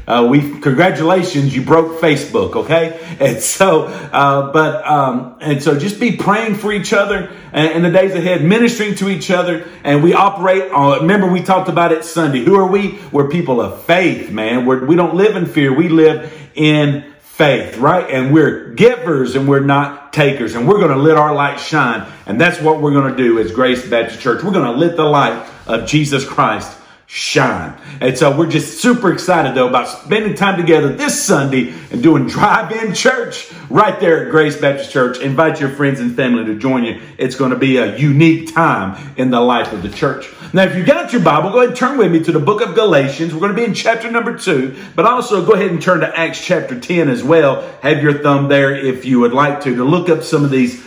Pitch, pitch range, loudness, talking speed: 155 Hz, 140-185 Hz, -13 LUFS, 225 wpm